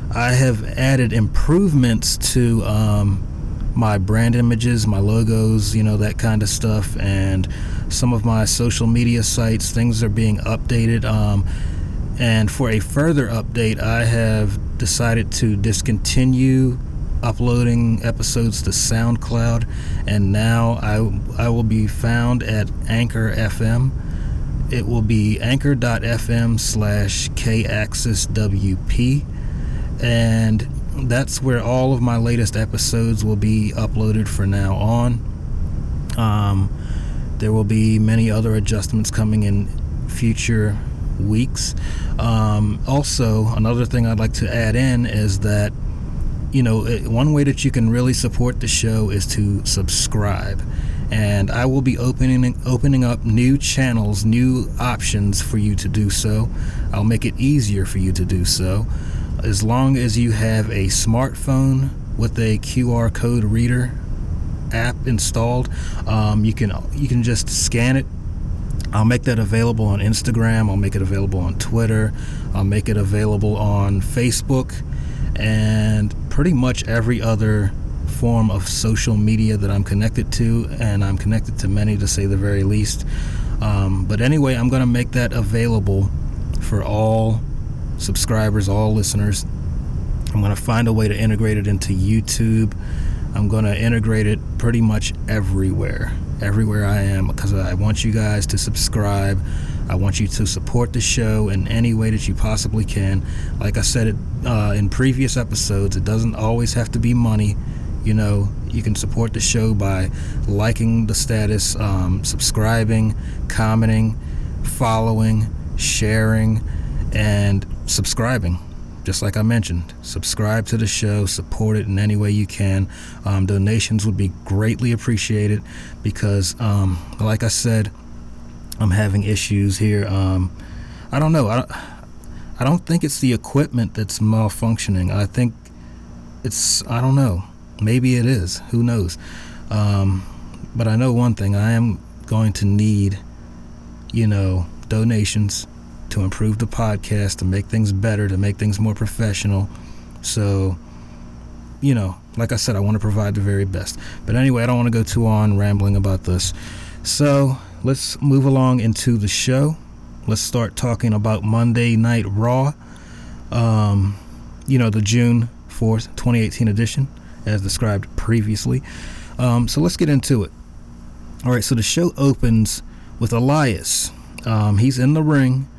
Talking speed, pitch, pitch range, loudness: 150 wpm, 110 Hz, 100-115 Hz, -19 LUFS